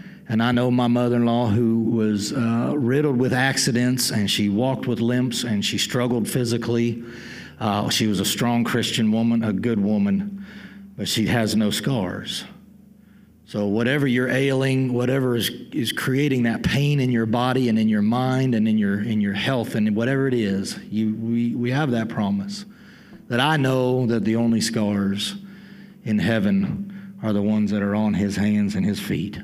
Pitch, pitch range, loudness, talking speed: 120 Hz, 110-135 Hz, -22 LUFS, 185 wpm